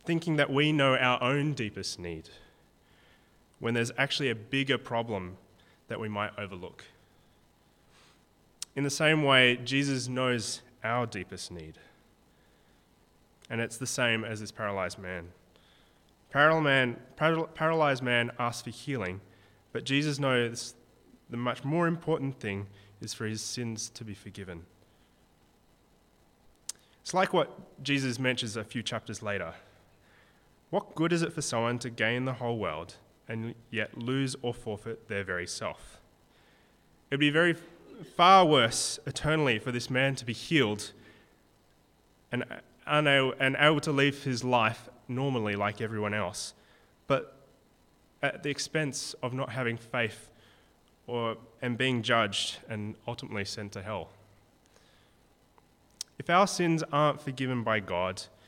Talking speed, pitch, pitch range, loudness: 135 wpm, 120 Hz, 105-135 Hz, -29 LUFS